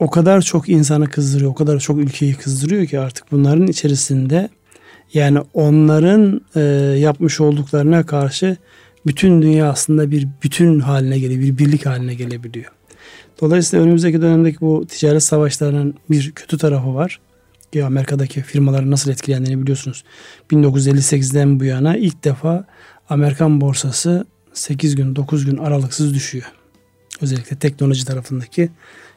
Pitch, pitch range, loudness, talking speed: 145 Hz, 135-155 Hz, -15 LUFS, 130 wpm